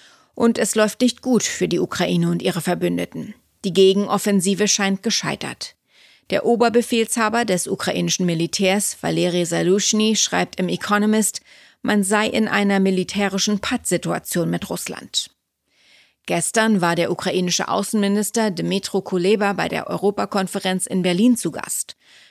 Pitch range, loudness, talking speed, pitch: 180-215 Hz, -20 LUFS, 125 wpm, 195 Hz